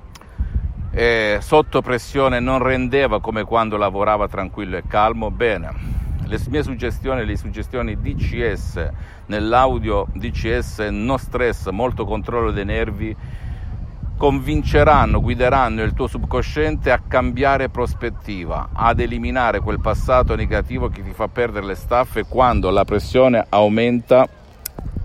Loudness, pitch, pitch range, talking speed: -19 LUFS, 110 Hz, 100-125 Hz, 115 wpm